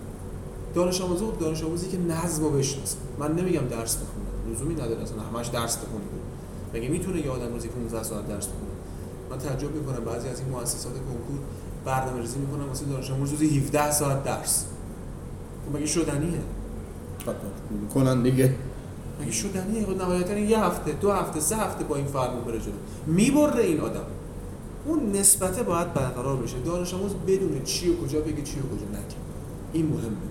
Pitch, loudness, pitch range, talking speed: 140 Hz, -27 LUFS, 115-165 Hz, 170 wpm